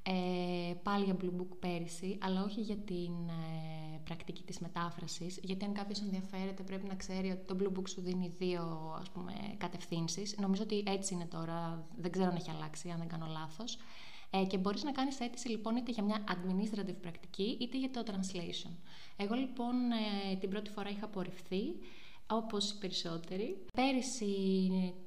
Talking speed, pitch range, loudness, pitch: 175 wpm, 175-205 Hz, -39 LUFS, 190 Hz